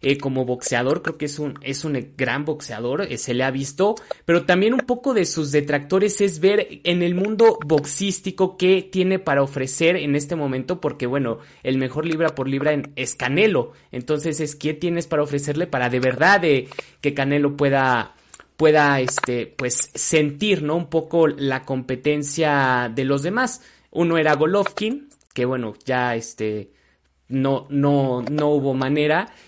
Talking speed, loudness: 170 wpm, -21 LUFS